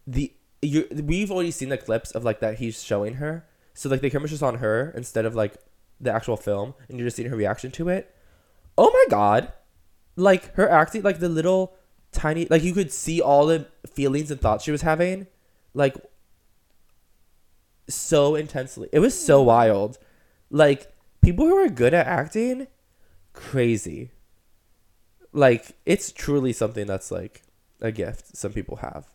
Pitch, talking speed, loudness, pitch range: 135 Hz, 165 wpm, -22 LUFS, 110-160 Hz